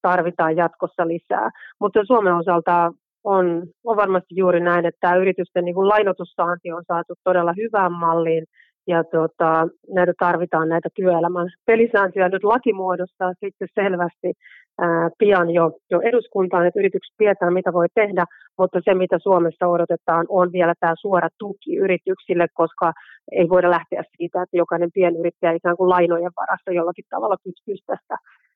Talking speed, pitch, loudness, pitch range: 145 wpm, 180 Hz, -20 LUFS, 170-190 Hz